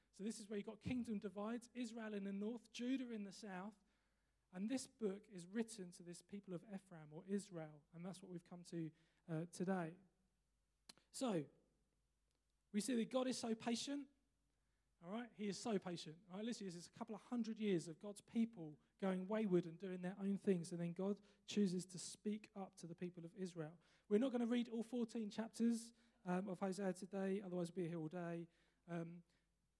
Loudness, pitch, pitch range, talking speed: -47 LUFS, 195 Hz, 175-220 Hz, 205 wpm